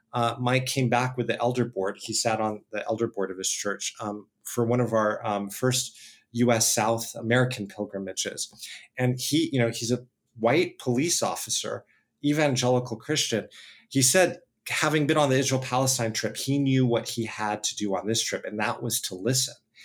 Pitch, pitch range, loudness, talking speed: 120 Hz, 110-130 Hz, -26 LUFS, 190 wpm